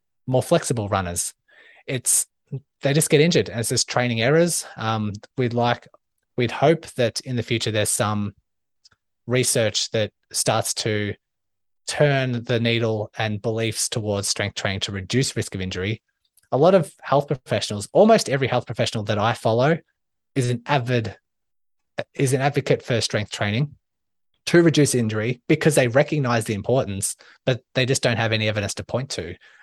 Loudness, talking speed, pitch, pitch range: -22 LUFS, 160 wpm, 120 Hz, 105-140 Hz